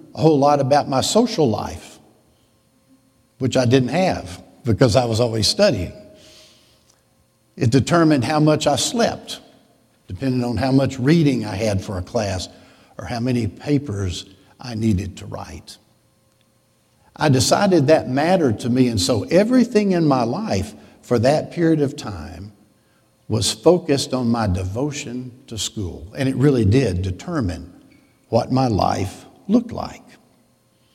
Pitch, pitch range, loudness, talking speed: 125 Hz, 110-145 Hz, -19 LUFS, 145 wpm